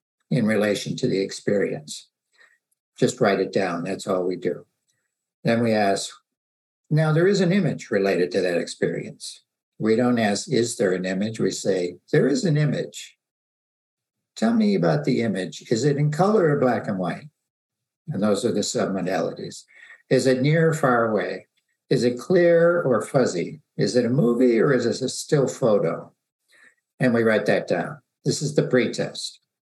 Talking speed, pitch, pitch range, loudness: 175 wpm, 125 Hz, 105-160 Hz, -22 LUFS